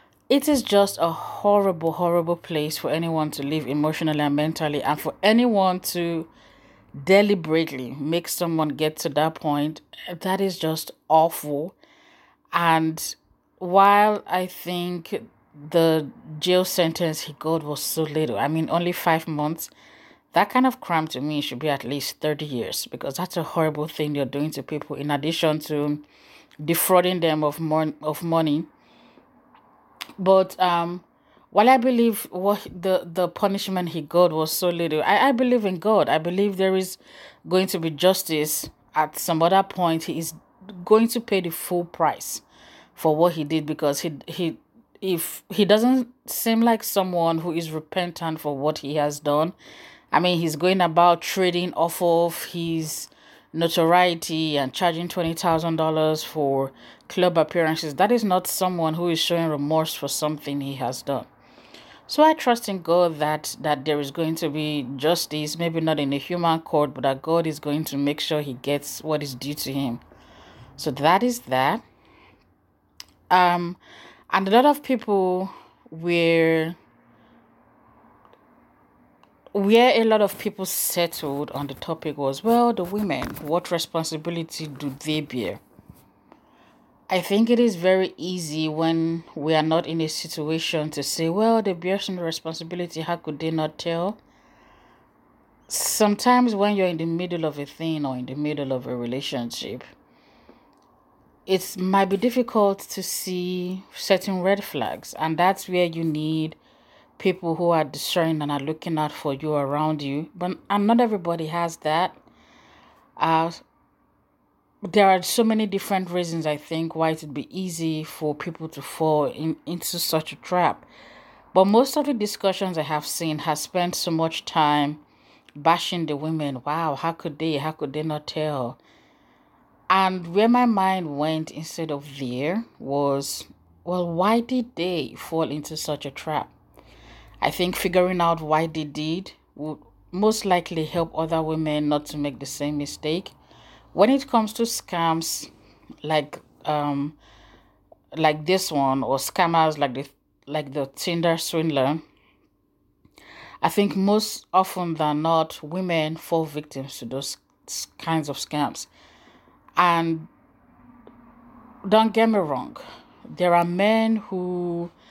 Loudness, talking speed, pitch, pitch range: -23 LUFS, 155 wpm, 165 Hz, 150-185 Hz